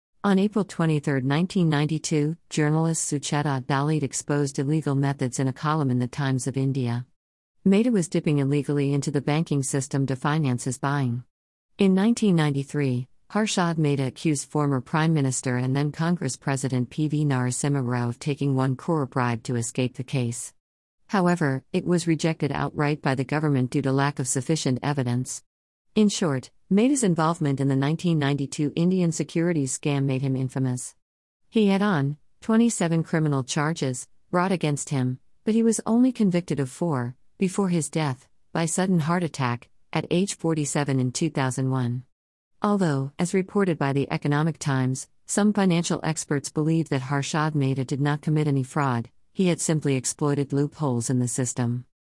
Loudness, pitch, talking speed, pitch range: -25 LUFS, 145 Hz, 160 wpm, 135-165 Hz